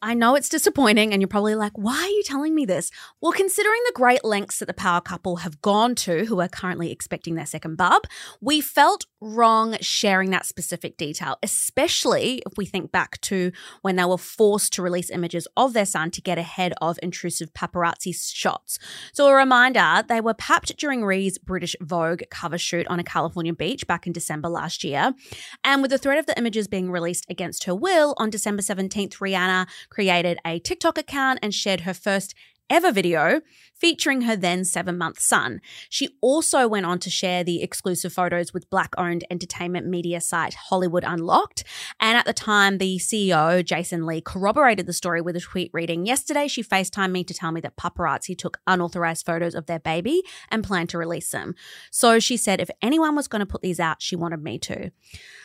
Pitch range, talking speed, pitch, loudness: 175-230 Hz, 200 wpm, 185 Hz, -22 LUFS